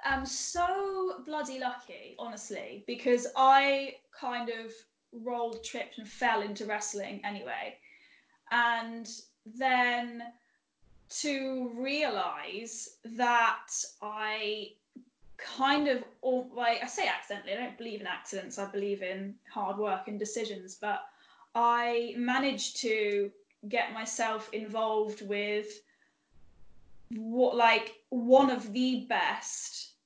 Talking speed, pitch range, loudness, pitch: 110 wpm, 215-255 Hz, -31 LUFS, 235 Hz